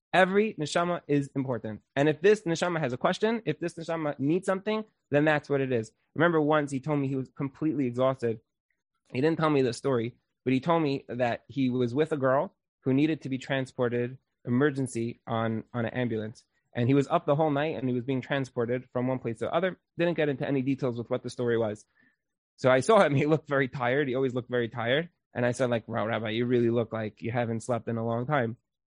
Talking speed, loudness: 235 wpm, -28 LUFS